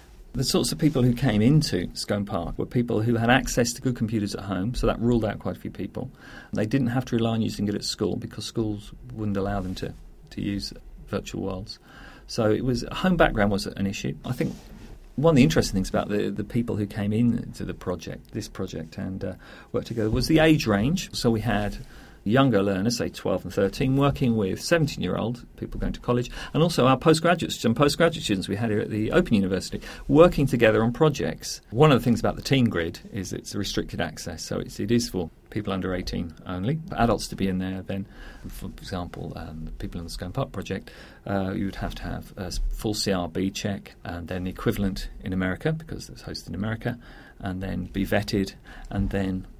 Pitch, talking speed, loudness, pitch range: 110 Hz, 220 wpm, -25 LUFS, 95-125 Hz